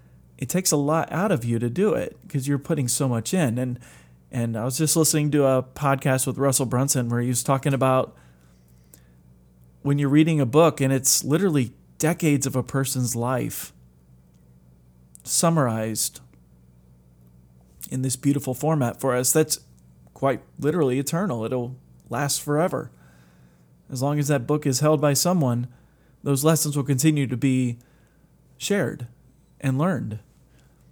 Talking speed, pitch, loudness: 150 wpm, 130 Hz, -23 LUFS